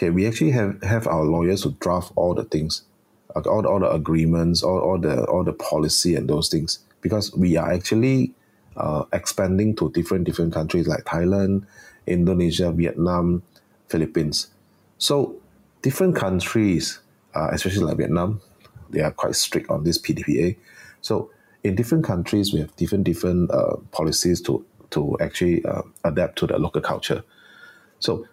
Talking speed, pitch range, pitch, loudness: 155 wpm, 85-105 Hz, 90 Hz, -22 LUFS